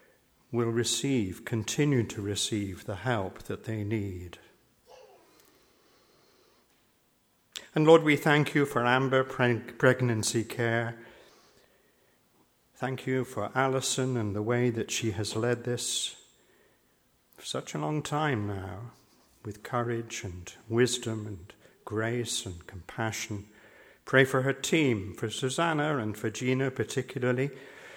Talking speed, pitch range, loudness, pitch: 120 wpm, 110-130 Hz, -29 LUFS, 120 Hz